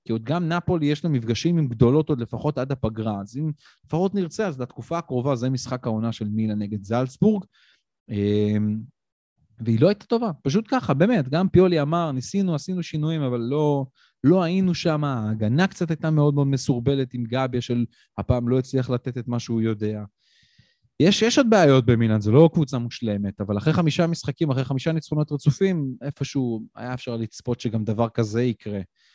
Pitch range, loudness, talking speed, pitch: 115-165 Hz, -23 LUFS, 180 wpm, 135 Hz